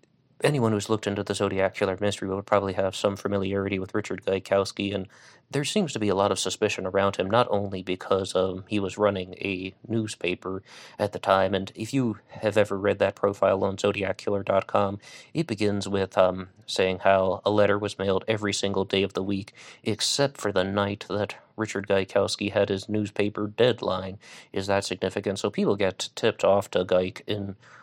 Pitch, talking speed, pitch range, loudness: 100 Hz, 190 wpm, 95-105 Hz, -26 LUFS